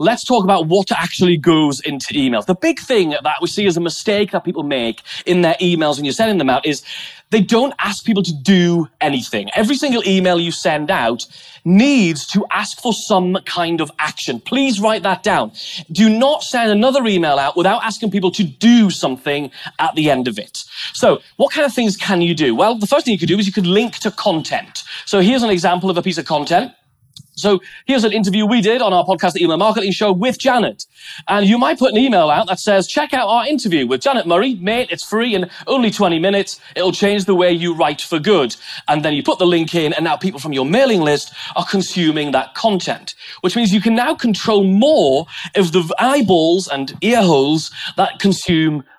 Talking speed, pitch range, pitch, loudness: 220 wpm, 170-225 Hz, 190 Hz, -15 LUFS